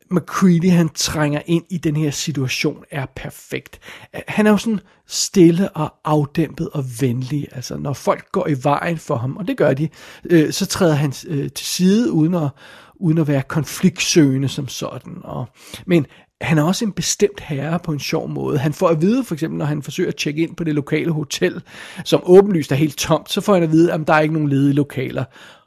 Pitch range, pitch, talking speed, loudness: 145-175 Hz, 160 Hz, 215 wpm, -18 LUFS